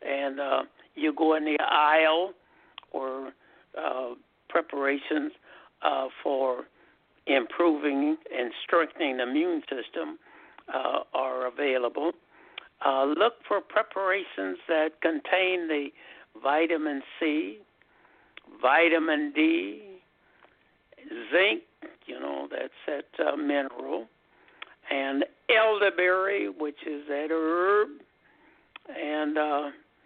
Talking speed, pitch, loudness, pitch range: 95 wpm, 160 Hz, -27 LUFS, 140-200 Hz